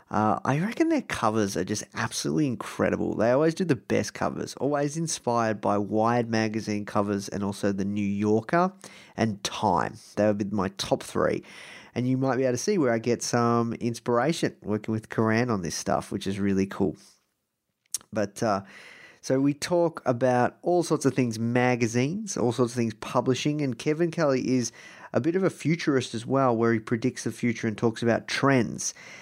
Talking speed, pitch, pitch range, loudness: 190 wpm, 120 Hz, 110-135 Hz, -26 LUFS